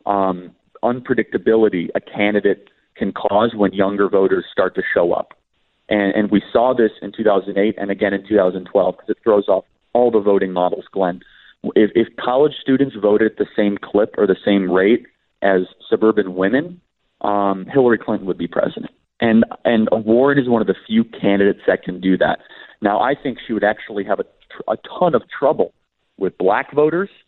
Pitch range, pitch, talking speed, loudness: 95-115 Hz, 105 Hz, 185 wpm, -18 LUFS